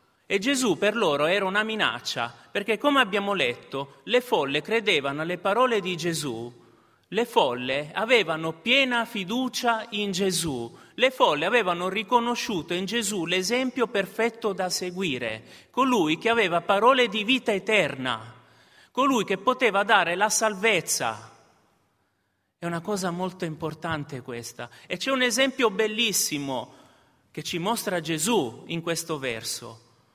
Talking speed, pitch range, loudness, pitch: 130 wpm, 140-225 Hz, -25 LUFS, 185 Hz